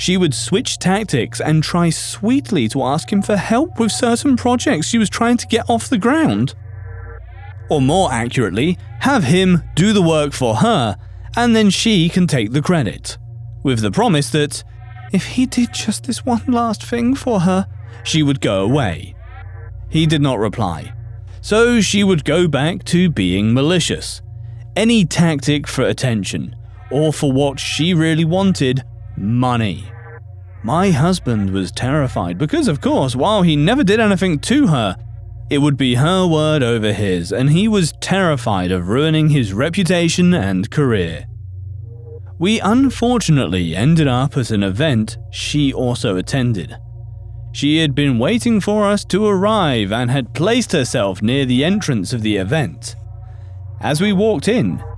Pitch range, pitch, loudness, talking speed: 110-185 Hz, 140 Hz, -16 LUFS, 155 wpm